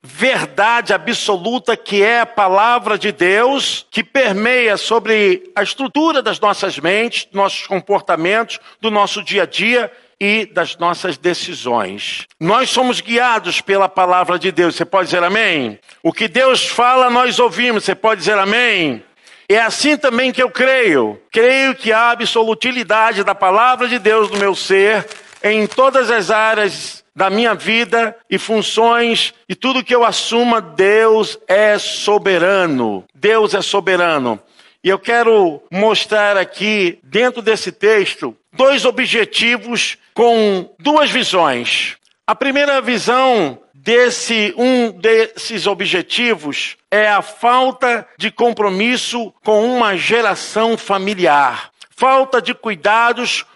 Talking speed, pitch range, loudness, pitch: 130 wpm, 200-245 Hz, -14 LUFS, 220 Hz